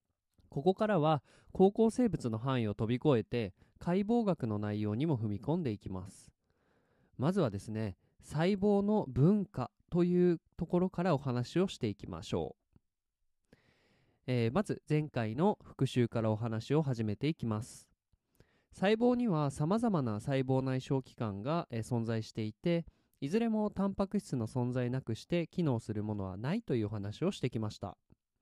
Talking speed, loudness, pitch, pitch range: 310 characters per minute, -34 LUFS, 130 Hz, 110-175 Hz